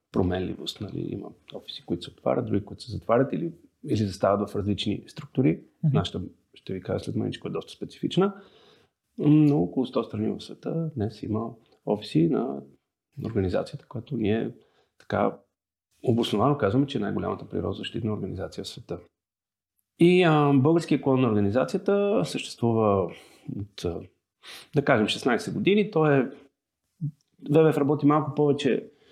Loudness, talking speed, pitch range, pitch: -26 LUFS, 135 wpm, 105-155 Hz, 135 Hz